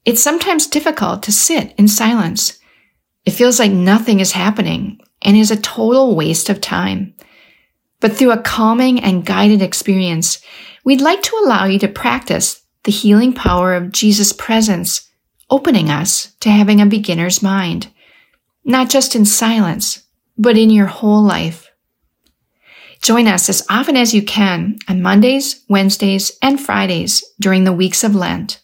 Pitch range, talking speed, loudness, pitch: 195-240 Hz, 155 wpm, -13 LUFS, 210 Hz